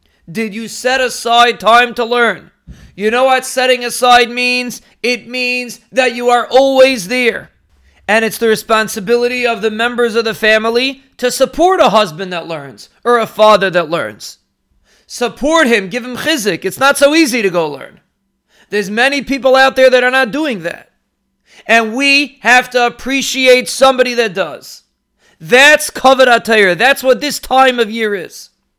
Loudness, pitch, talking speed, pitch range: -11 LUFS, 240 Hz, 165 wpm, 220-260 Hz